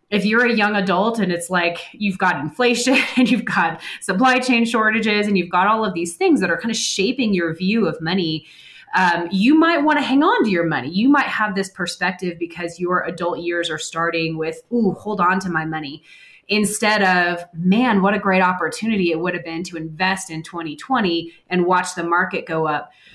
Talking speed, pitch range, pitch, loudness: 215 wpm, 170-215 Hz, 185 Hz, -19 LUFS